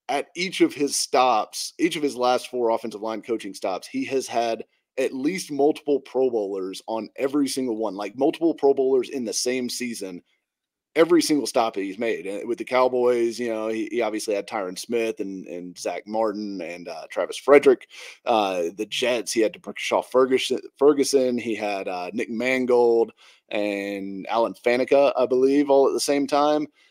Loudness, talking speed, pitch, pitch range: -23 LUFS, 185 wpm, 125 Hz, 110-145 Hz